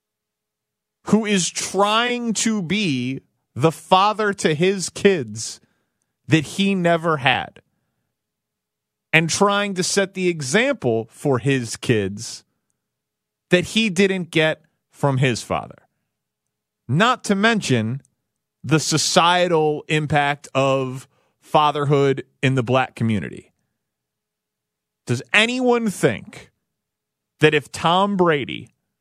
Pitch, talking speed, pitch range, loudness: 155 Hz, 100 wpm, 130-195 Hz, -19 LUFS